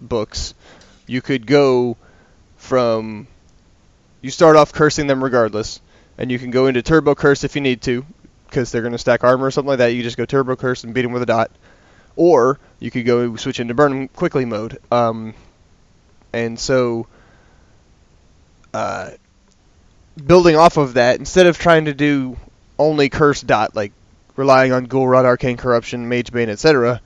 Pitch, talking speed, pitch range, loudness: 125 Hz, 175 wpm, 110-135 Hz, -16 LUFS